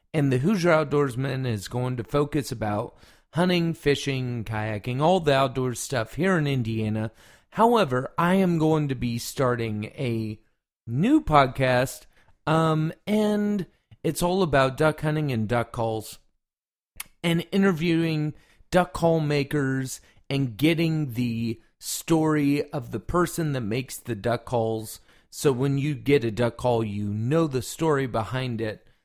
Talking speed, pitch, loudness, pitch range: 145 wpm, 135 Hz, -25 LUFS, 115-160 Hz